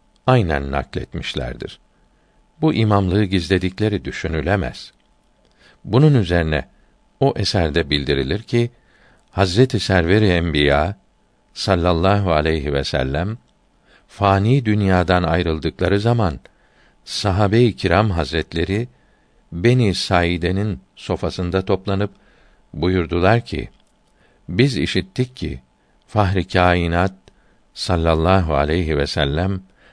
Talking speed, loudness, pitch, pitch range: 80 wpm, -19 LUFS, 95 Hz, 85-105 Hz